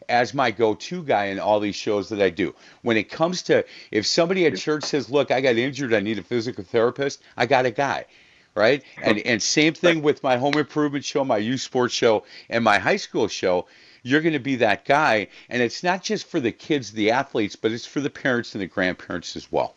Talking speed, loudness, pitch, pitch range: 235 wpm, -22 LUFS, 130 Hz, 115-150 Hz